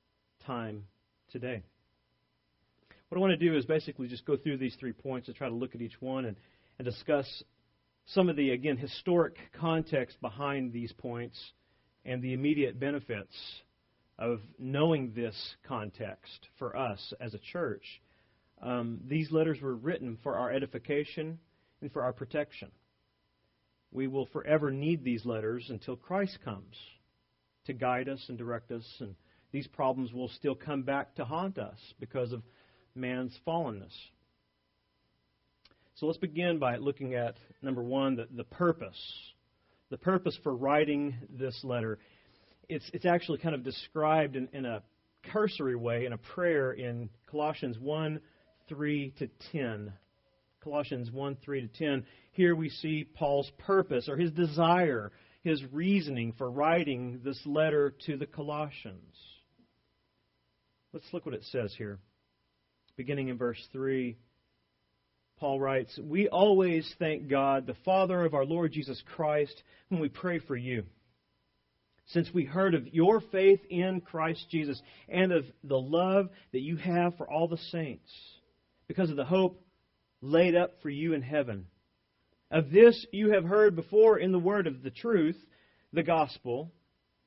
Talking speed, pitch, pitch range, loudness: 150 wpm, 135 Hz, 115-160 Hz, -31 LUFS